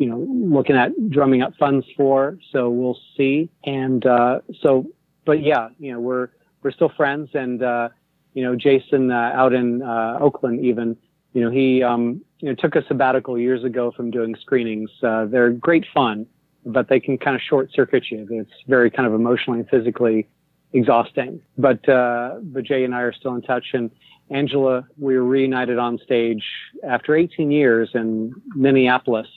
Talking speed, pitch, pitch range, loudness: 180 wpm, 130 Hz, 120-140 Hz, -20 LUFS